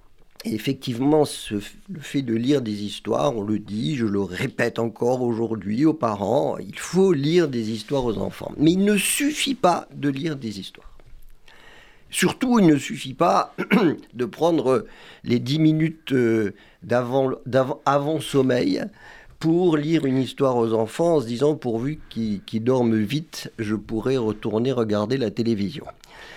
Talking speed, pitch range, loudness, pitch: 155 wpm, 115-155 Hz, -22 LUFS, 130 Hz